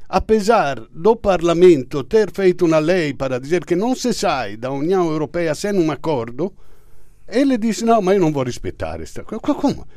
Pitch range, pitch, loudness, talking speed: 145-215 Hz, 175 Hz, -18 LUFS, 195 wpm